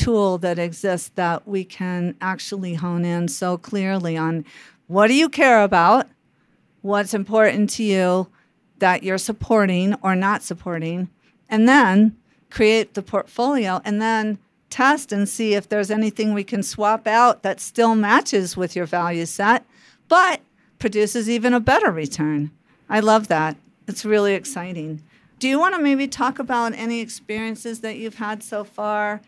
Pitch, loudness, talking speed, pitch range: 210 Hz, -20 LUFS, 160 wpm, 185-225 Hz